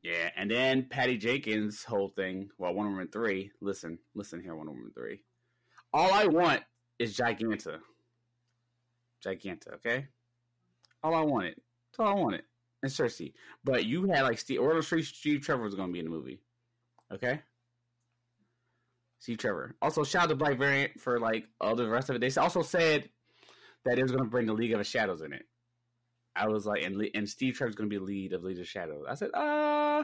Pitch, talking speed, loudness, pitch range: 120 Hz, 200 wpm, -31 LUFS, 105-130 Hz